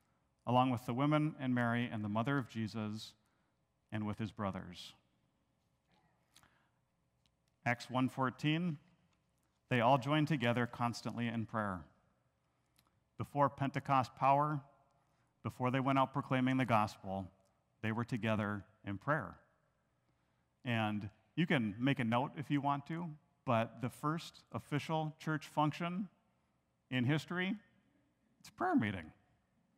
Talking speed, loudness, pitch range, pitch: 125 wpm, -37 LUFS, 105-145 Hz, 125 Hz